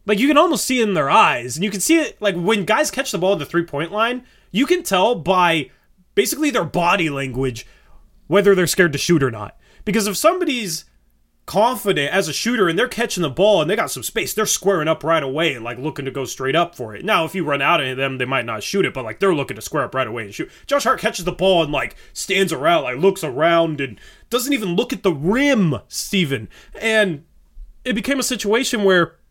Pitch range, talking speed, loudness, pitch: 150-225 Hz, 245 wpm, -18 LUFS, 190 Hz